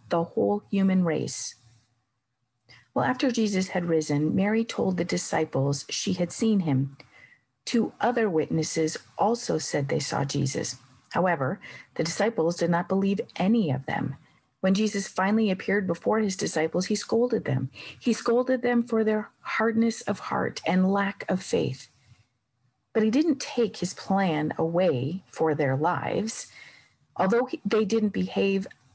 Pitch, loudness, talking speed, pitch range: 190 Hz, -26 LUFS, 145 wpm, 155-220 Hz